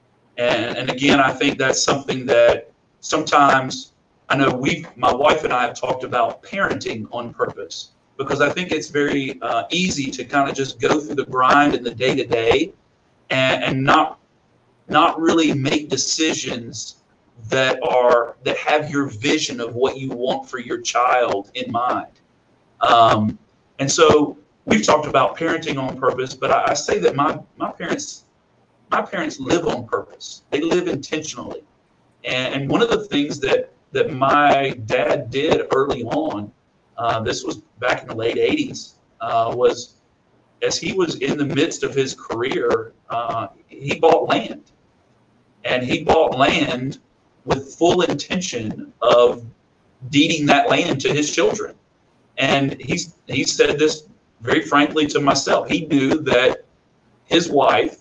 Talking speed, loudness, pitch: 155 wpm, -19 LUFS, 150 Hz